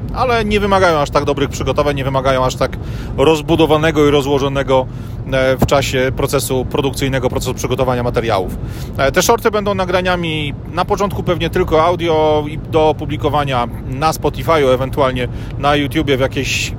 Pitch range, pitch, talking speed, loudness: 130-155 Hz, 140 Hz, 145 wpm, -15 LUFS